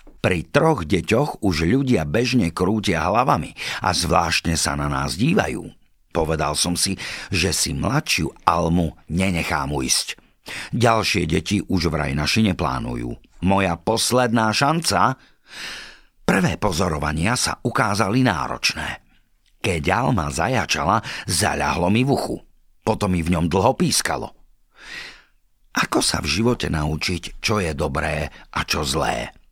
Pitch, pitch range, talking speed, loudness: 90 Hz, 75-110 Hz, 125 wpm, -21 LUFS